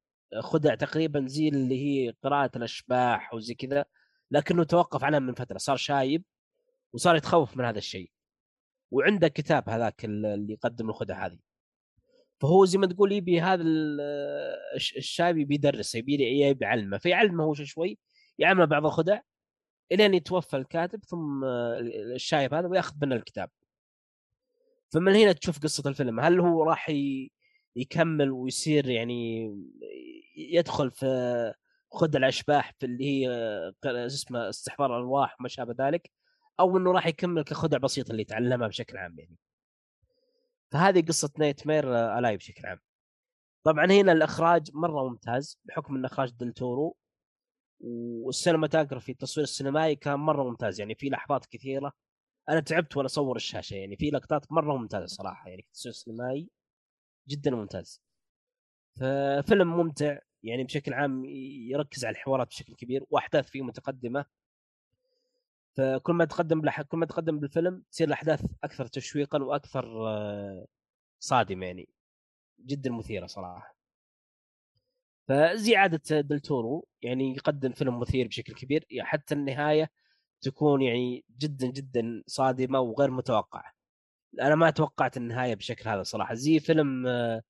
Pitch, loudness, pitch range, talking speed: 140 Hz, -28 LUFS, 125-165 Hz, 130 wpm